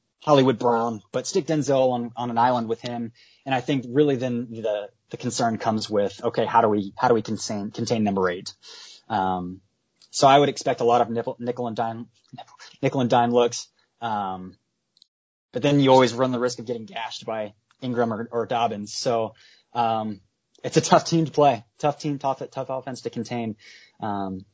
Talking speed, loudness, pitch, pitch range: 195 wpm, -24 LUFS, 120 Hz, 110-130 Hz